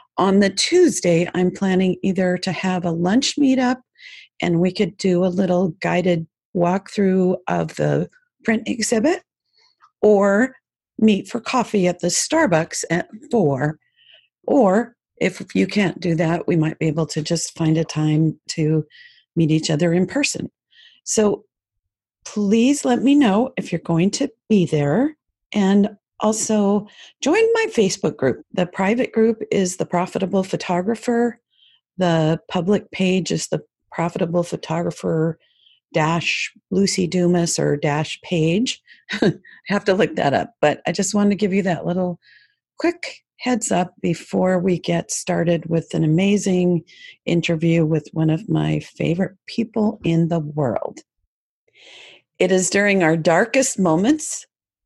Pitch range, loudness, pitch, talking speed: 170-225 Hz, -20 LUFS, 185 Hz, 140 wpm